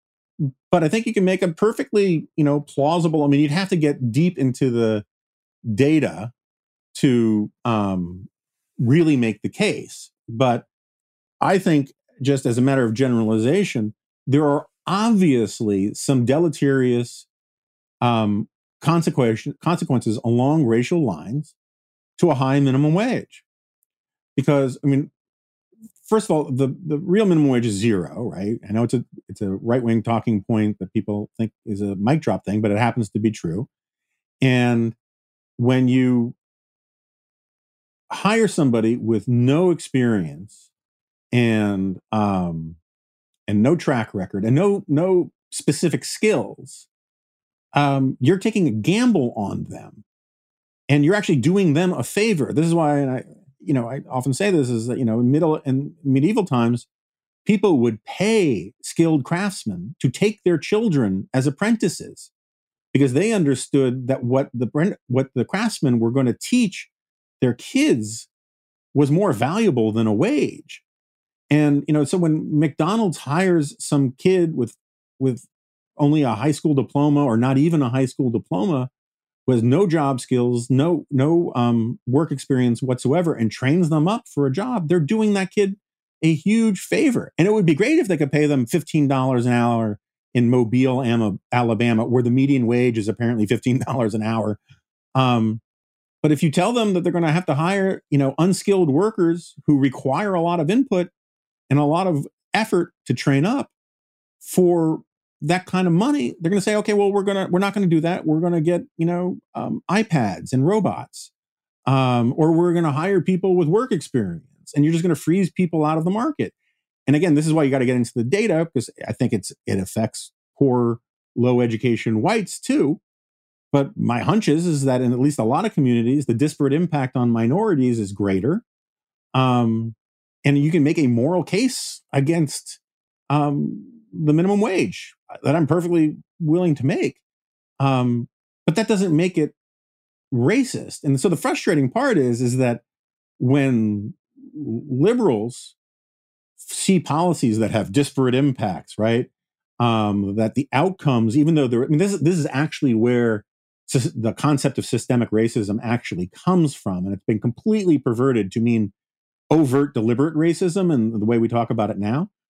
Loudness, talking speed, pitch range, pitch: -20 LUFS, 170 wpm, 120-170 Hz, 140 Hz